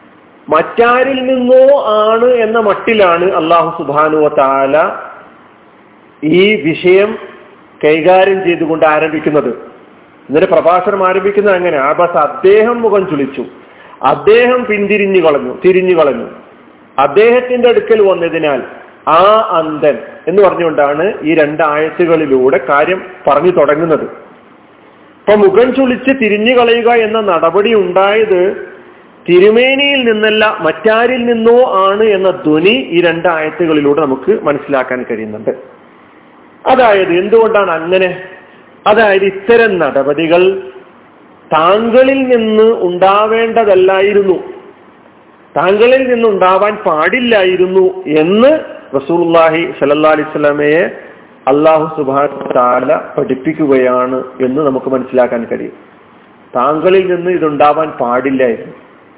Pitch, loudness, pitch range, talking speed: 185 Hz, -10 LUFS, 155-225 Hz, 85 wpm